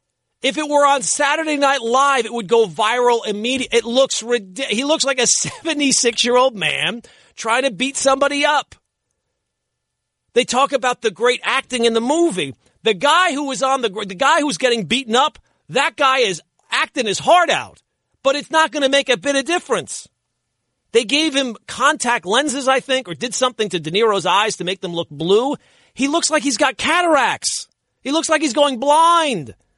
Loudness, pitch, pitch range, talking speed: -17 LUFS, 265 Hz, 230-285 Hz, 190 wpm